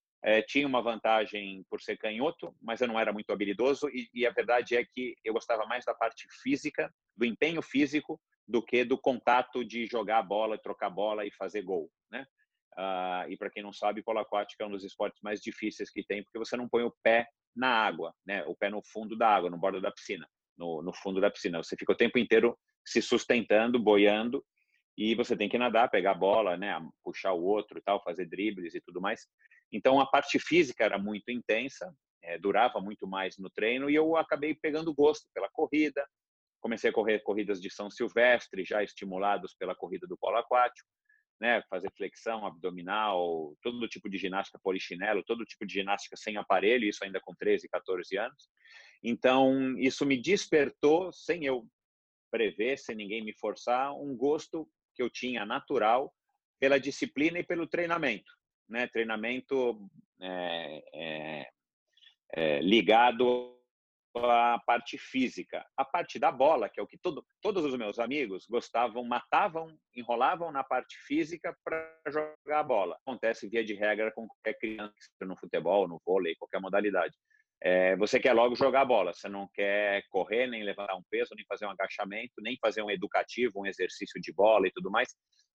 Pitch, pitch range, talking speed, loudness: 120 Hz, 105-145 Hz, 185 wpm, -31 LUFS